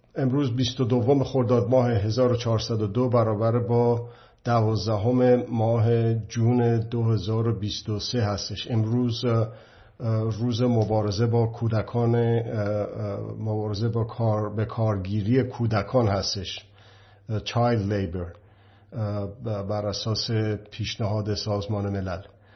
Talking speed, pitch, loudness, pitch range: 85 wpm, 110 Hz, -25 LUFS, 105-120 Hz